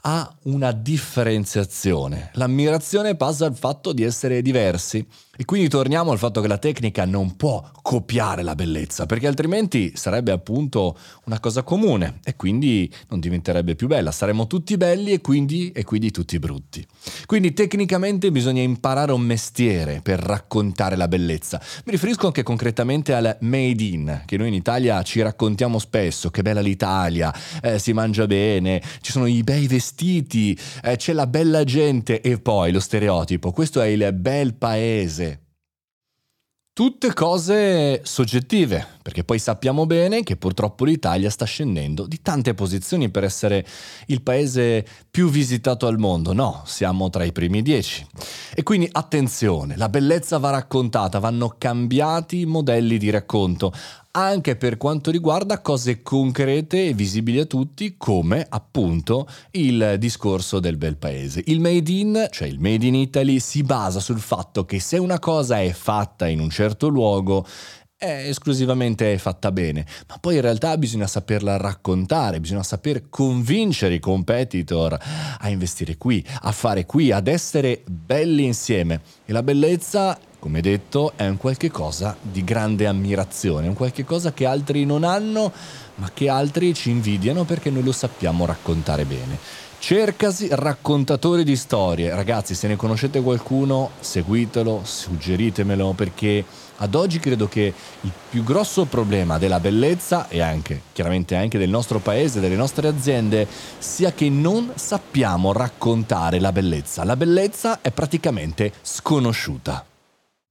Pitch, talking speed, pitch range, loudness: 120 Hz, 150 wpm, 100-145 Hz, -21 LUFS